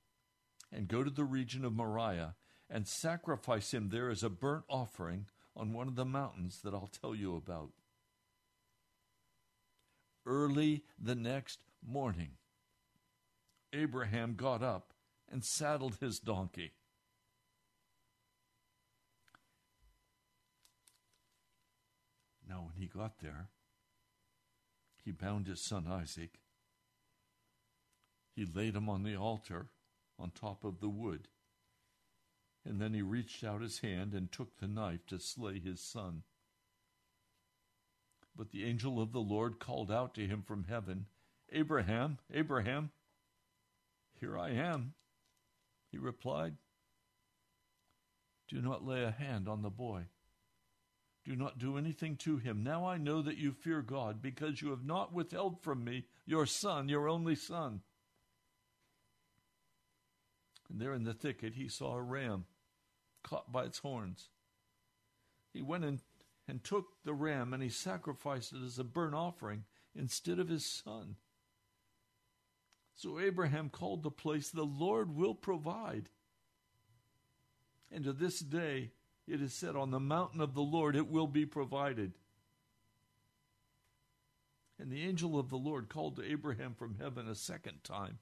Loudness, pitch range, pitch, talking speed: -40 LUFS, 105-140 Hz, 115 Hz, 135 wpm